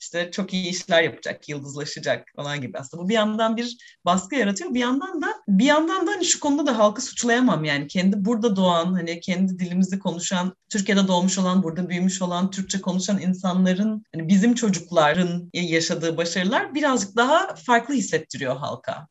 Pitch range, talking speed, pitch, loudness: 175-235 Hz, 170 wpm, 190 Hz, -22 LUFS